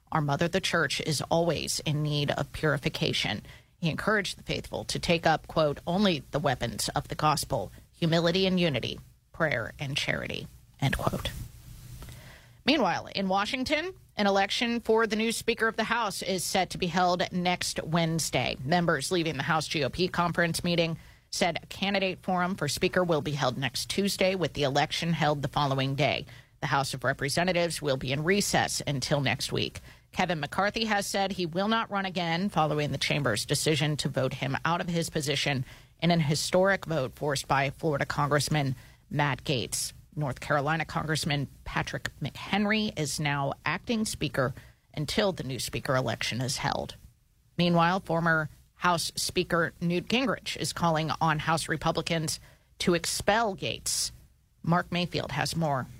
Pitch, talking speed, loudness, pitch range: 160 Hz, 160 wpm, -28 LUFS, 140-180 Hz